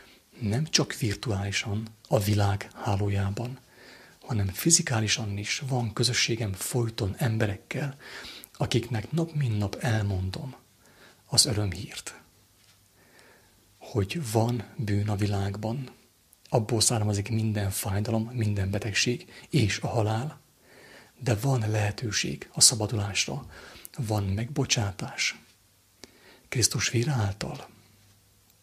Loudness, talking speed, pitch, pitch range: -27 LUFS, 90 wpm, 110 Hz, 100-125 Hz